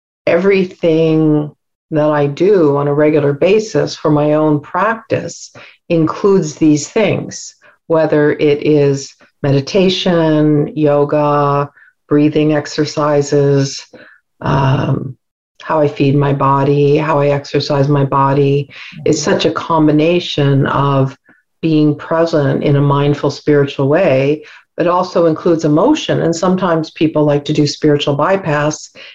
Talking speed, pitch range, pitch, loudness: 115 wpm, 145-160 Hz, 150 Hz, -13 LUFS